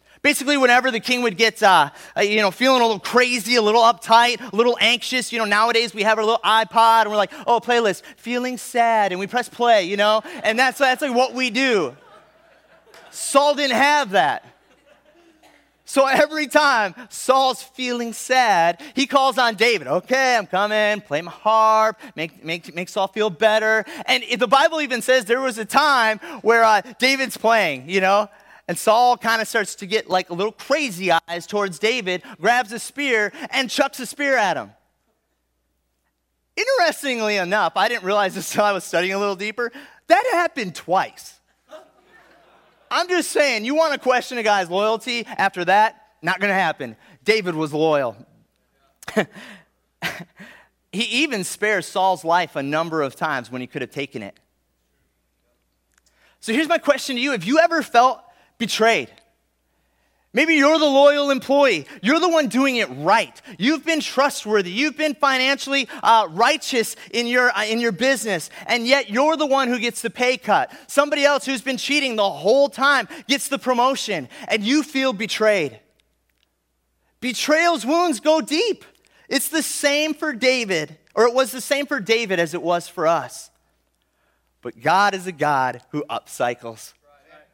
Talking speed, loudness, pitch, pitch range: 170 wpm, -19 LUFS, 230 Hz, 195-270 Hz